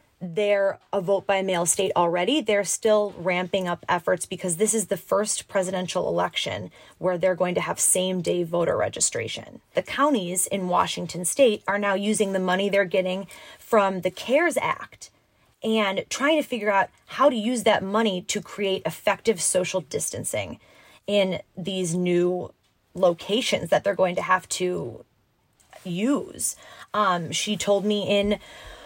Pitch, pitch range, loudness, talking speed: 195 Hz, 185-210 Hz, -24 LUFS, 155 wpm